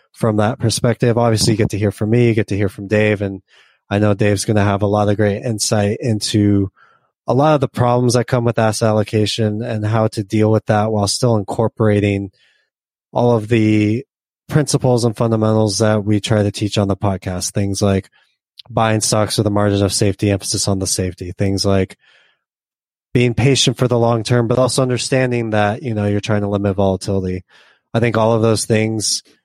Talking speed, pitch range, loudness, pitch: 205 wpm, 100-115 Hz, -16 LUFS, 110 Hz